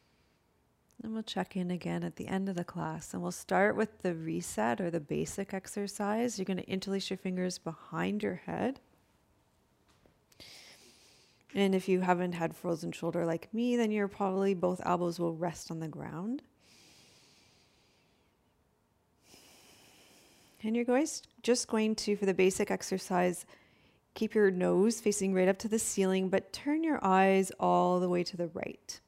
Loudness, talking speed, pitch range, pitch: -32 LUFS, 165 wpm, 180-210 Hz, 190 Hz